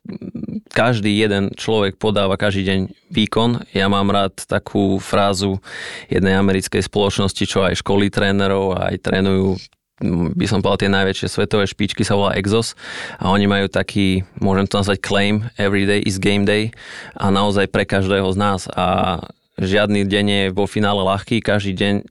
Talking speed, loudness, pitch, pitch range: 160 wpm, -18 LUFS, 100 Hz, 95-105 Hz